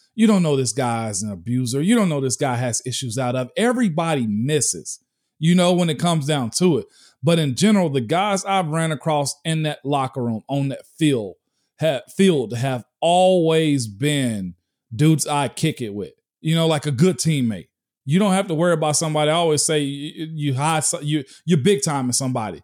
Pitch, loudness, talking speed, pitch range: 150 Hz, -20 LUFS, 205 wpm, 130-170 Hz